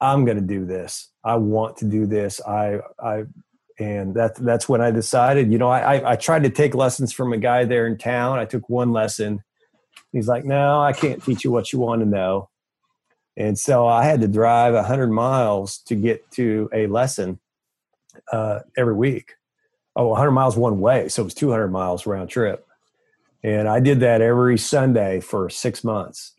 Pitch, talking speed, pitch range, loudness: 115 Hz, 195 wpm, 105-130 Hz, -20 LUFS